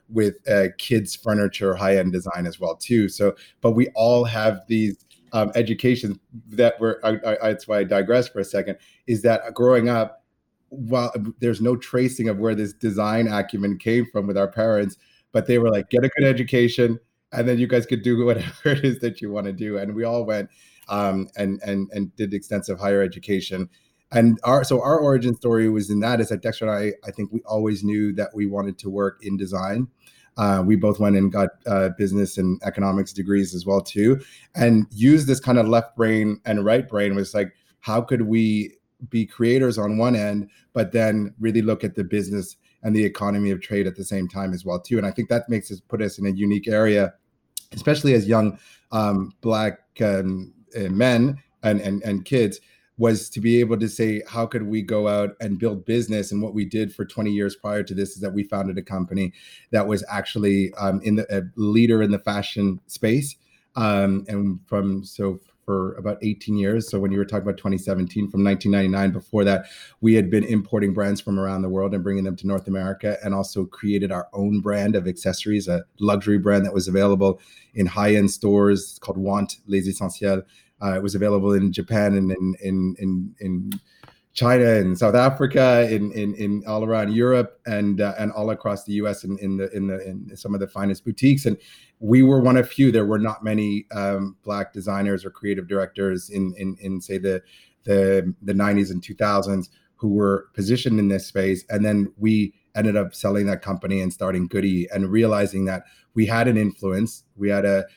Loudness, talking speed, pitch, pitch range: -22 LUFS, 210 wpm, 105 Hz, 100-115 Hz